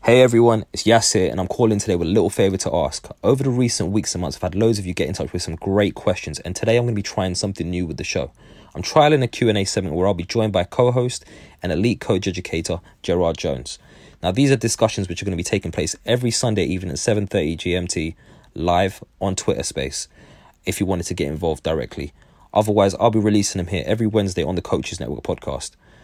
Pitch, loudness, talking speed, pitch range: 100 Hz, -20 LUFS, 235 wpm, 90-115 Hz